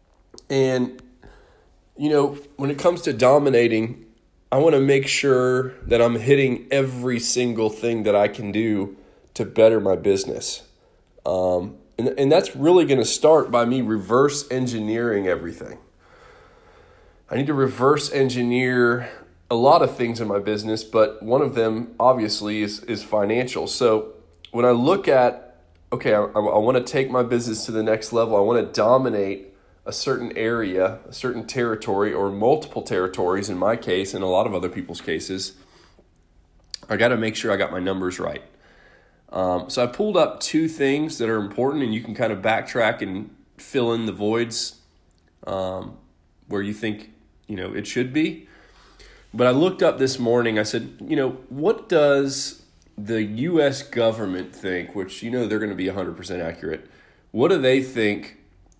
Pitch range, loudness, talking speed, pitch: 100-130 Hz, -21 LUFS, 170 wpm, 115 Hz